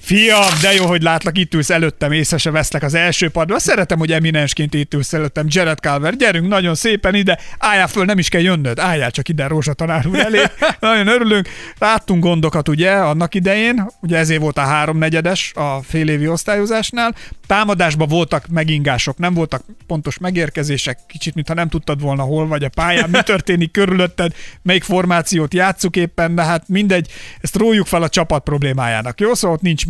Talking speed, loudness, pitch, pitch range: 180 wpm, -15 LUFS, 170 Hz, 155-185 Hz